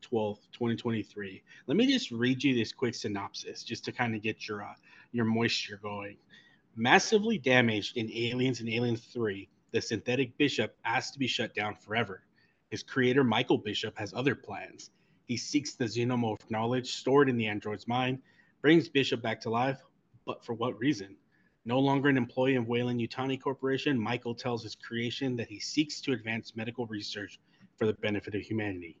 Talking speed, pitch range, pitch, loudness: 180 wpm, 110-130 Hz, 120 Hz, -31 LUFS